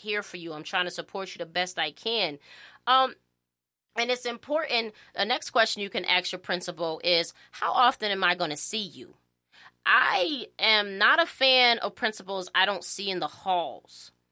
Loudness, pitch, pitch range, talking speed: -26 LUFS, 190 Hz, 170-225 Hz, 190 wpm